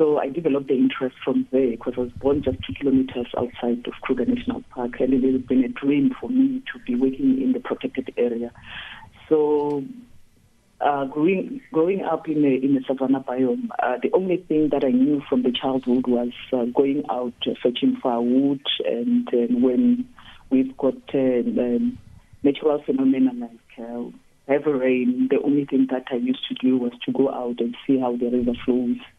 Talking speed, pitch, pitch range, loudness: 190 wpm, 130 Hz, 125-145 Hz, -22 LUFS